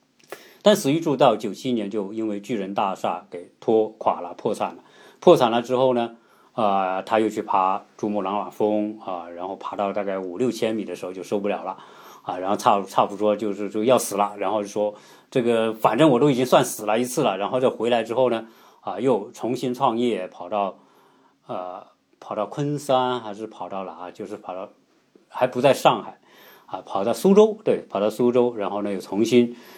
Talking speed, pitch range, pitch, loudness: 290 characters per minute, 100-125 Hz, 110 Hz, -23 LUFS